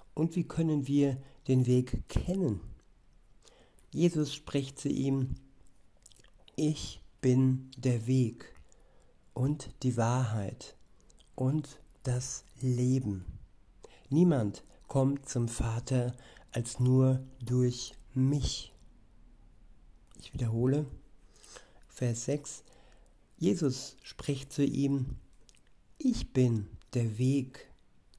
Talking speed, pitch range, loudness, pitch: 85 wpm, 125-140 Hz, -32 LUFS, 130 Hz